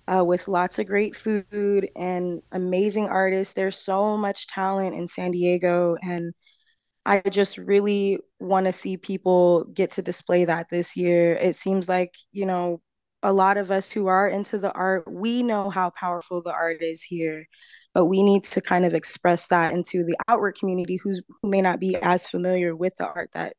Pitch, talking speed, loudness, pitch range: 185 Hz, 190 wpm, -23 LUFS, 175-200 Hz